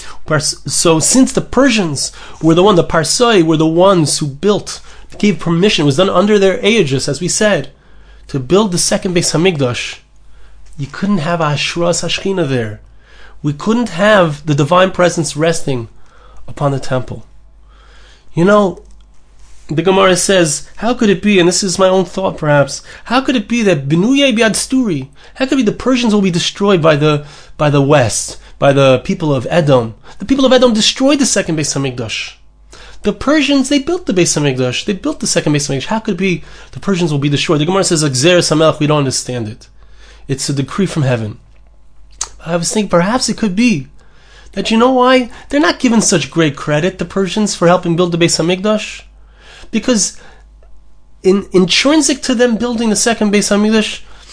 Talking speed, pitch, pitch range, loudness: 190 wpm, 180 Hz, 150-210 Hz, -13 LUFS